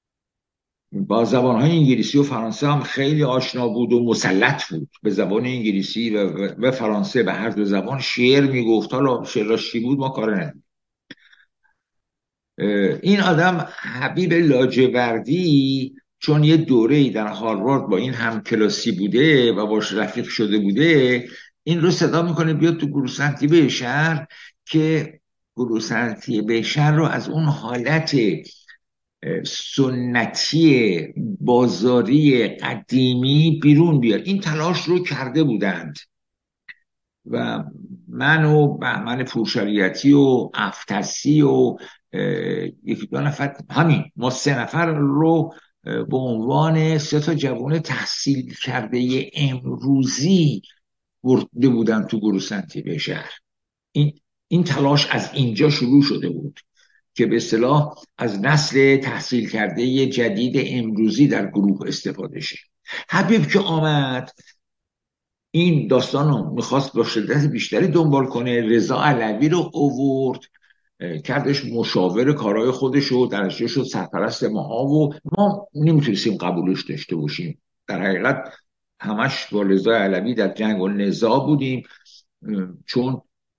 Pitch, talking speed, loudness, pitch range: 135 Hz, 125 wpm, -19 LUFS, 115-150 Hz